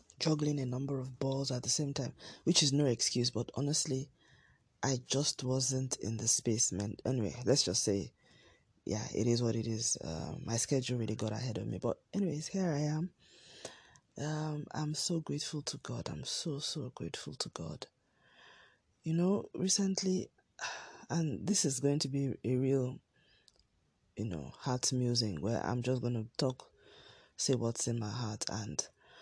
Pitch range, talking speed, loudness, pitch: 120-150 Hz, 170 wpm, -35 LUFS, 135 Hz